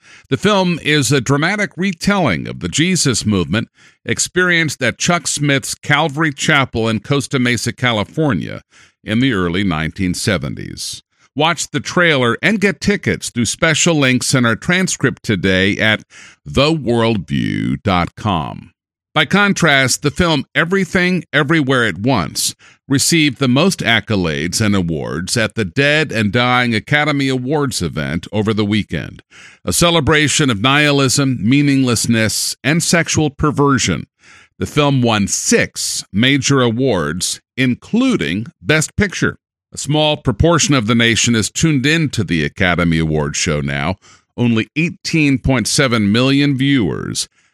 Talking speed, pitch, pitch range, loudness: 125 wpm, 130 Hz, 110-150 Hz, -15 LUFS